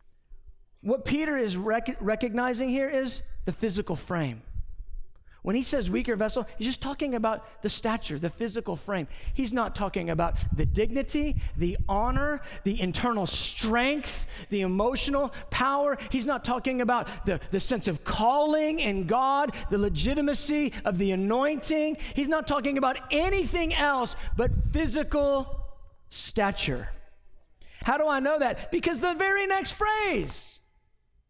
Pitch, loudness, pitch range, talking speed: 240 Hz, -28 LUFS, 195-285 Hz, 140 wpm